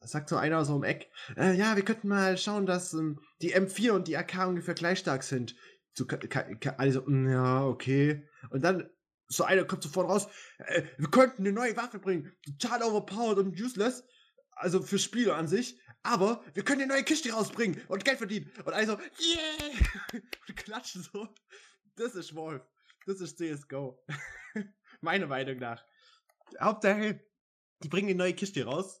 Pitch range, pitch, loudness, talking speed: 160-220 Hz, 190 Hz, -31 LUFS, 175 wpm